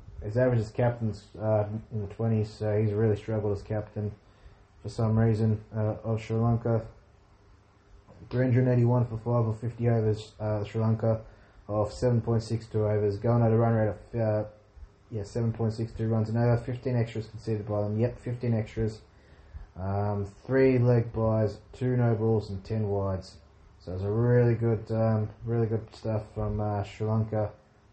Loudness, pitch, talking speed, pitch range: -28 LUFS, 110 Hz, 180 wpm, 105-115 Hz